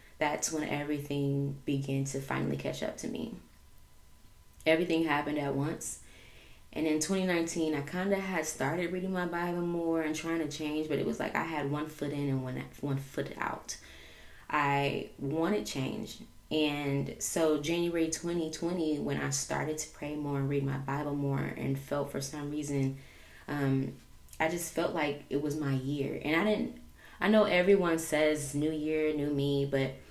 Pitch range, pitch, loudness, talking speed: 135-160 Hz, 145 Hz, -32 LUFS, 175 wpm